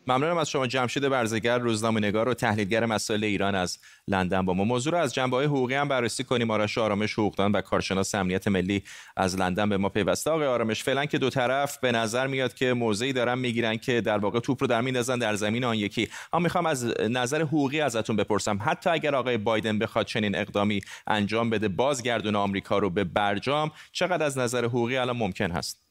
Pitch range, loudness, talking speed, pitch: 105-130 Hz, -26 LUFS, 205 wpm, 115 Hz